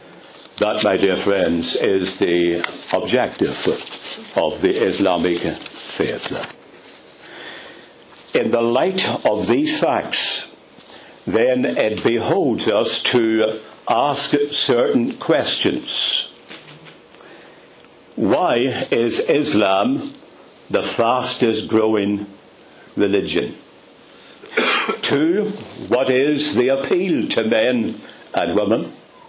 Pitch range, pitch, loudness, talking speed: 100-135 Hz, 110 Hz, -18 LUFS, 85 wpm